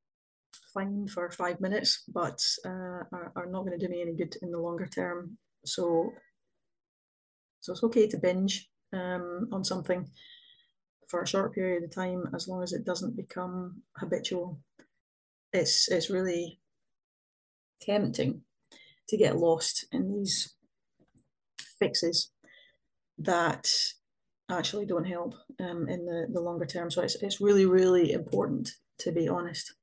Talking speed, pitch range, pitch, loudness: 140 wpm, 175-200 Hz, 180 Hz, -30 LUFS